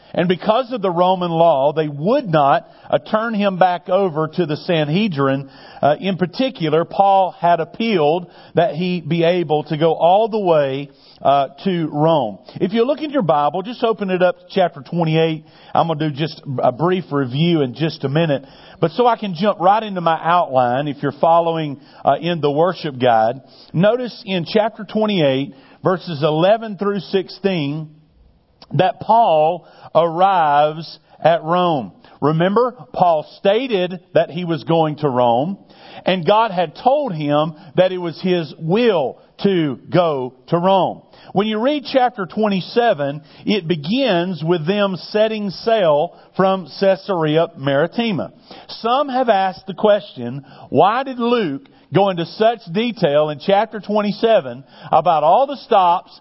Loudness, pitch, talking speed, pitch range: -18 LUFS, 175 Hz, 155 wpm, 155-205 Hz